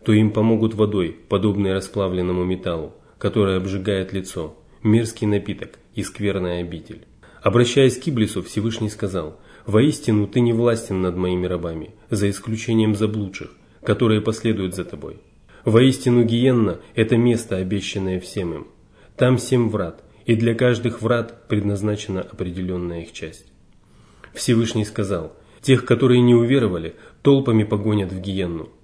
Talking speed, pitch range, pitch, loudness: 130 wpm, 95-115 Hz, 105 Hz, -20 LUFS